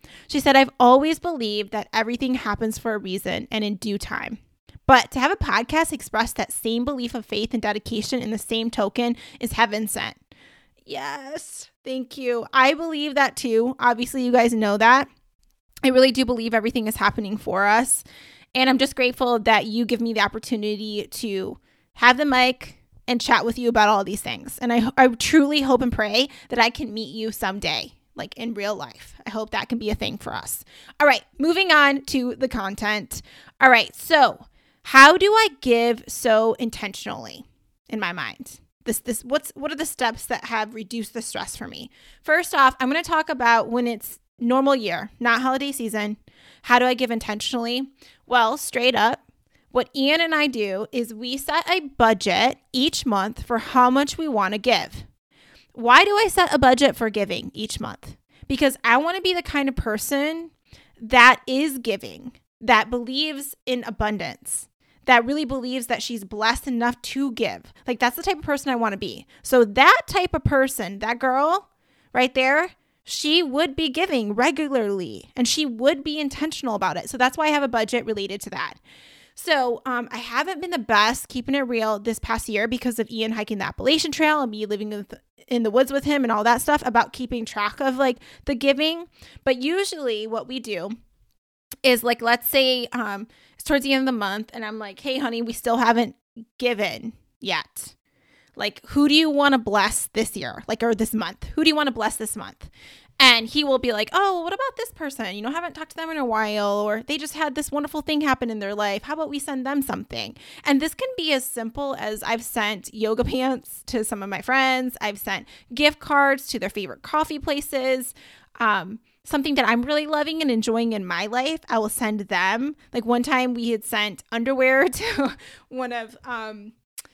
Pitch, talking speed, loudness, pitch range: 245 Hz, 205 wpm, -21 LUFS, 225-280 Hz